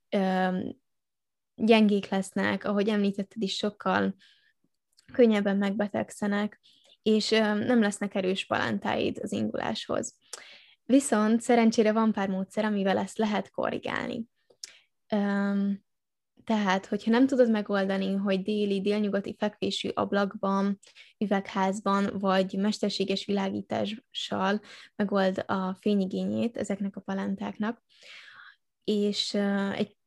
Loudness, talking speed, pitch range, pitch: -28 LUFS, 90 wpm, 195-215 Hz, 205 Hz